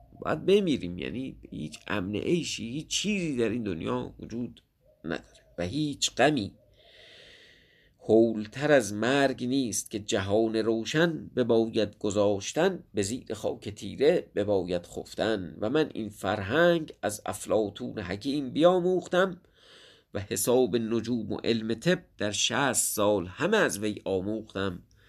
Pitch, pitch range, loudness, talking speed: 115 Hz, 105-145 Hz, -28 LUFS, 130 wpm